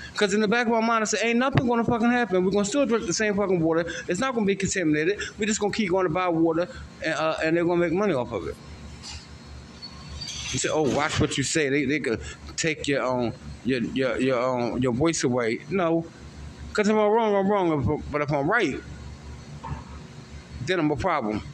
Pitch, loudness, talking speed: 160 Hz, -24 LUFS, 225 wpm